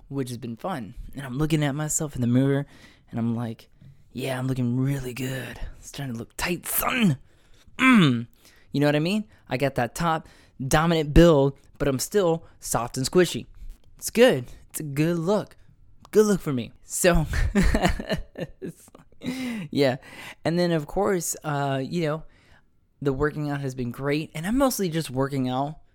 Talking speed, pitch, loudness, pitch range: 175 wpm, 140 Hz, -25 LUFS, 120-160 Hz